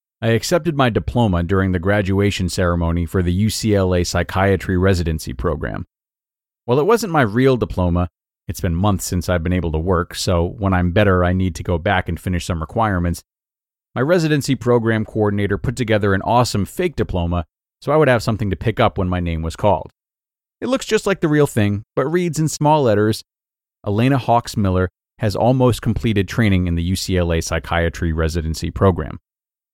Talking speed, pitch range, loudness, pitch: 180 wpm, 90-120 Hz, -18 LUFS, 100 Hz